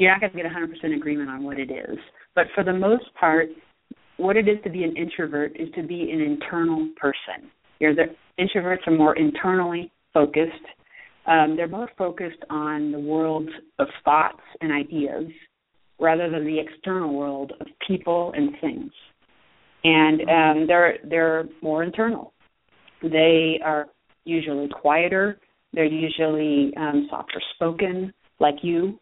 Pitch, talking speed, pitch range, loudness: 165 Hz, 150 wpm, 155-185 Hz, -23 LUFS